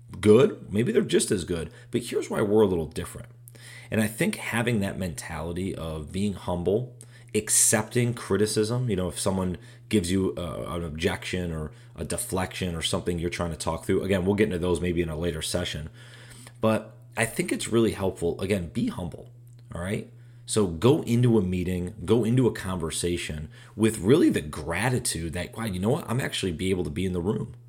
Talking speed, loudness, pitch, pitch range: 195 wpm, -26 LUFS, 105 Hz, 90-120 Hz